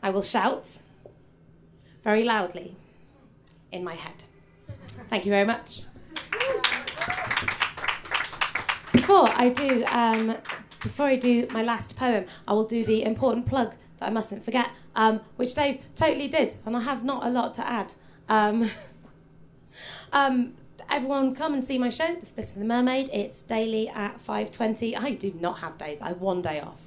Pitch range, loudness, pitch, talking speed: 215-260 Hz, -26 LUFS, 230 Hz, 165 wpm